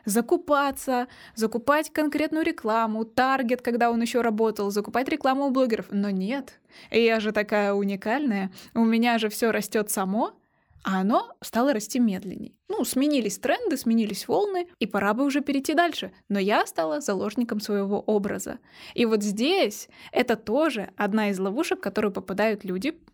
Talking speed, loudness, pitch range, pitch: 155 wpm, -25 LUFS, 210-280 Hz, 230 Hz